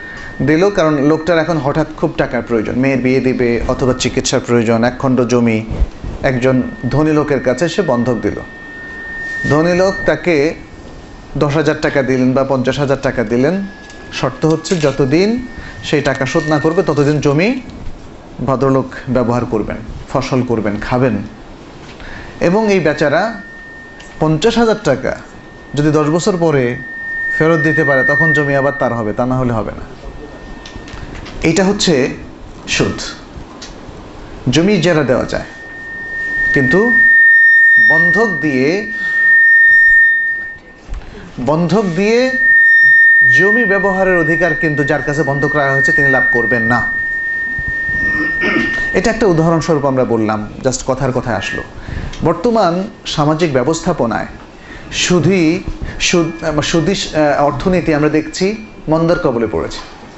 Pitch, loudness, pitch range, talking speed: 155 Hz, -12 LUFS, 130-205 Hz, 120 wpm